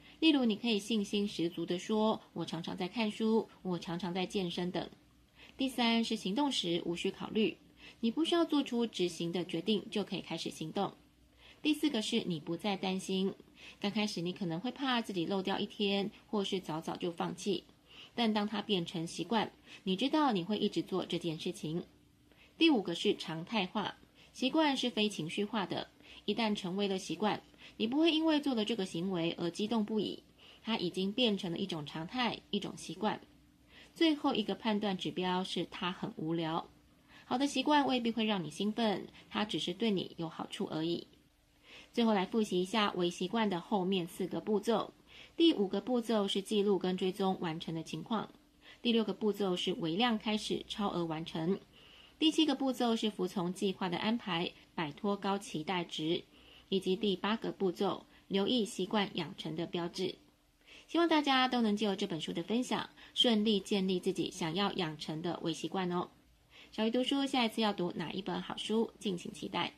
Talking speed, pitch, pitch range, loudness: 270 characters per minute, 200 Hz, 175-220 Hz, -34 LUFS